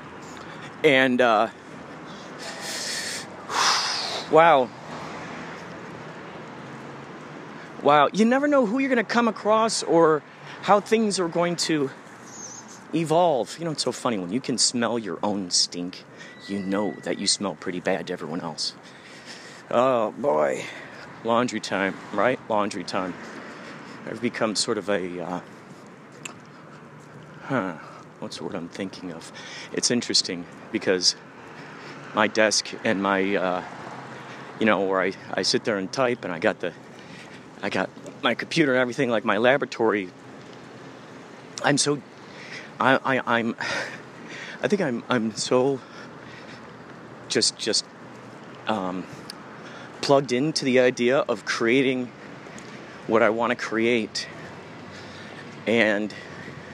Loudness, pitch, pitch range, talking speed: -23 LUFS, 125 Hz, 100-155 Hz, 125 wpm